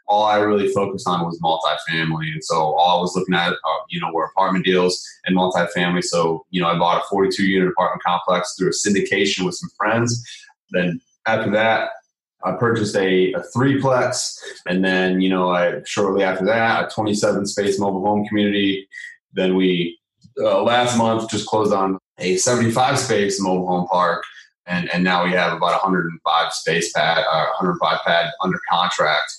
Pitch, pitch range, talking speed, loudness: 95 Hz, 90-105 Hz, 175 wpm, -19 LUFS